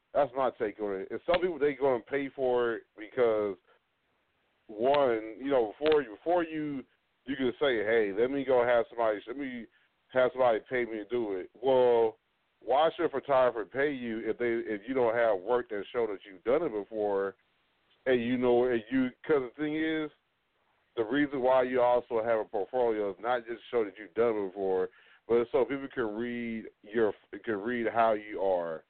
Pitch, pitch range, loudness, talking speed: 125 Hz, 110-140 Hz, -30 LUFS, 200 wpm